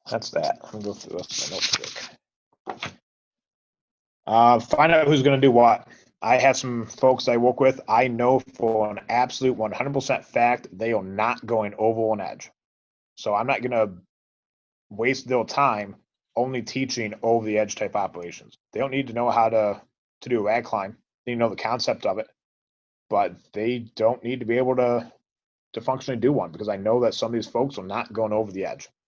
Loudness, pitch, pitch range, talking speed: -23 LUFS, 120 Hz, 110-130 Hz, 200 wpm